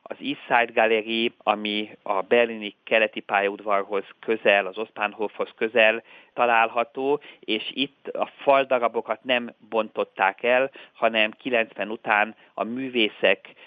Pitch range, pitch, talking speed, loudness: 105-120 Hz, 110 Hz, 115 wpm, -24 LUFS